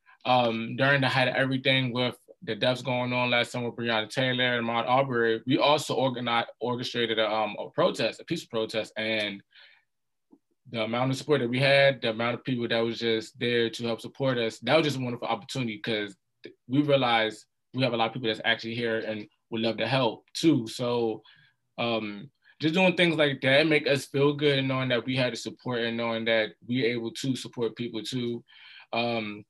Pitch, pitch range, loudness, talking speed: 120 Hz, 115-130 Hz, -27 LUFS, 210 wpm